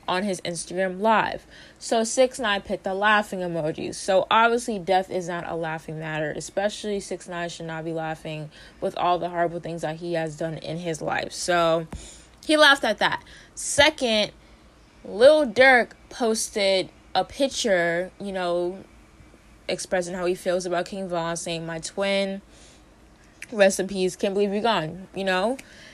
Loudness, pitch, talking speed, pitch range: -24 LUFS, 185 Hz, 155 wpm, 170-210 Hz